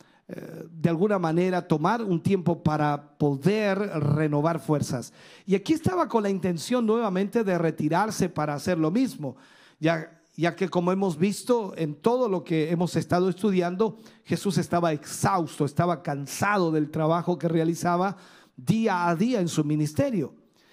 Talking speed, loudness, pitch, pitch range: 150 wpm, -26 LUFS, 175 Hz, 160-195 Hz